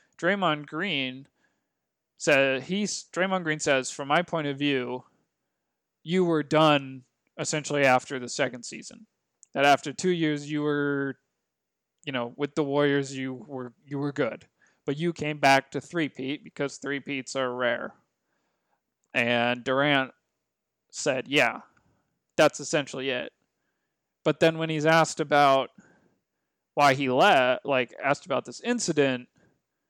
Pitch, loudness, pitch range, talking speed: 145 Hz, -26 LUFS, 135-155 Hz, 135 wpm